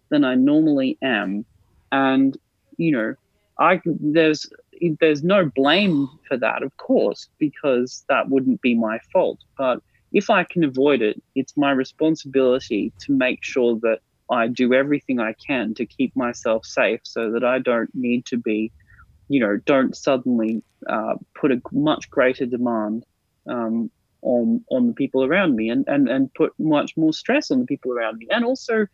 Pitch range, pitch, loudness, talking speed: 115-175 Hz, 135 Hz, -21 LUFS, 170 wpm